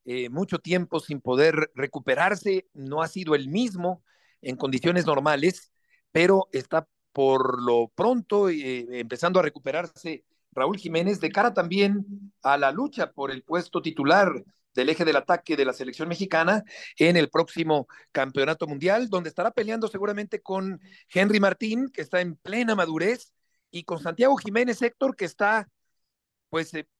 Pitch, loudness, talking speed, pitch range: 170 Hz, -25 LUFS, 155 wpm, 145-200 Hz